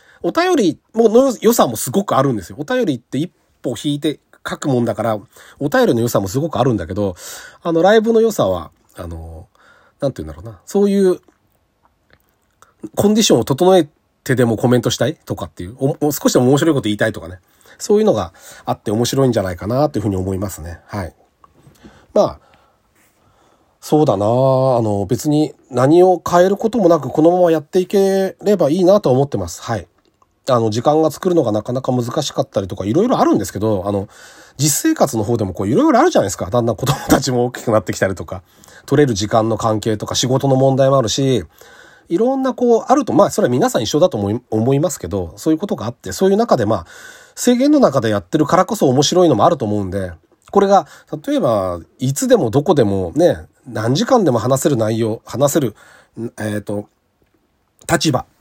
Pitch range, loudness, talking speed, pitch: 110-175 Hz, -16 LUFS, 400 characters per minute, 130 Hz